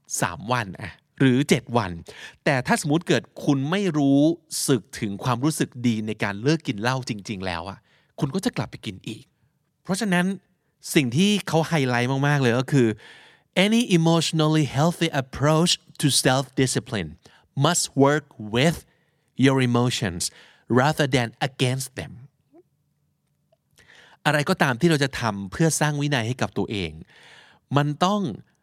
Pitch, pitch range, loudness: 140 Hz, 120-165 Hz, -23 LUFS